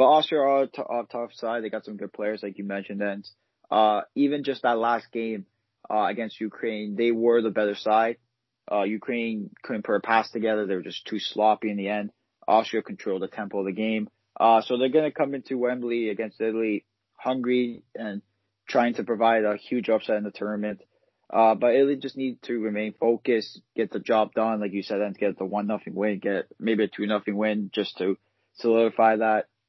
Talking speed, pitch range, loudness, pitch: 210 wpm, 105-120 Hz, -26 LUFS, 110 Hz